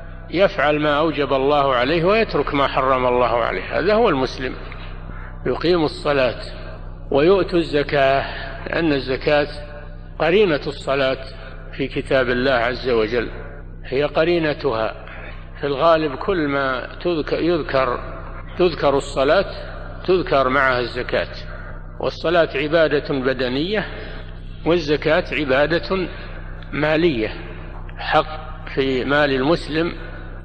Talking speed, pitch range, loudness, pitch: 95 wpm, 90-150 Hz, -19 LUFS, 135 Hz